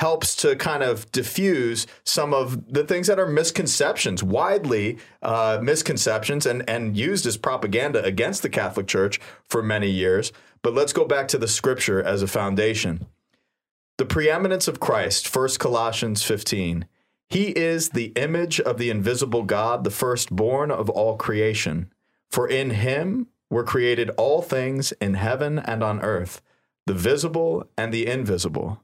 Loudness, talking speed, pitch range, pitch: -23 LUFS, 155 wpm, 110-150 Hz, 120 Hz